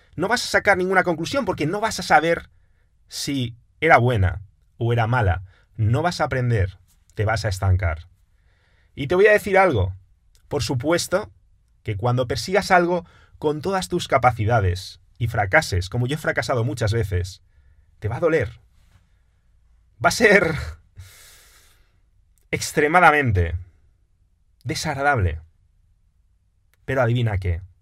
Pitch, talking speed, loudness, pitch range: 105 Hz, 130 wpm, -21 LUFS, 90-145 Hz